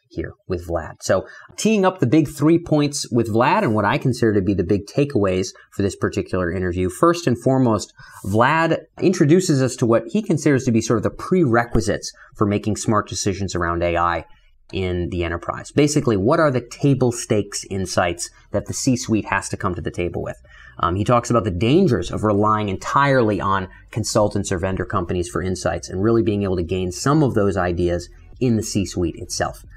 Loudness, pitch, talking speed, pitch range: -20 LUFS, 110 Hz, 200 wpm, 95-130 Hz